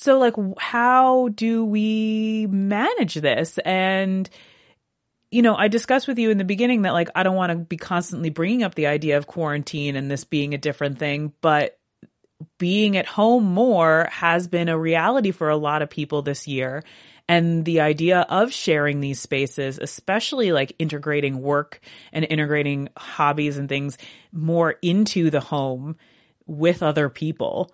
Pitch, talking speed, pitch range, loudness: 165 Hz, 165 wpm, 150-200 Hz, -21 LUFS